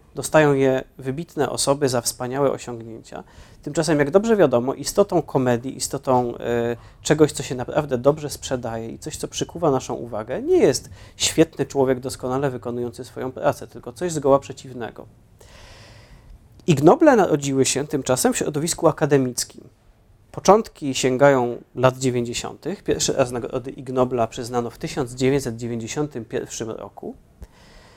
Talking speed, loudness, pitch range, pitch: 125 wpm, -21 LUFS, 120-145 Hz, 130 Hz